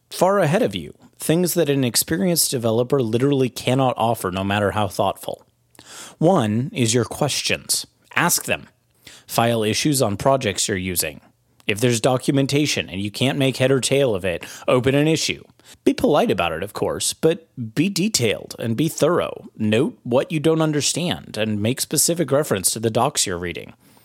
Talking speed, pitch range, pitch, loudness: 170 wpm, 110-145 Hz, 130 Hz, -20 LUFS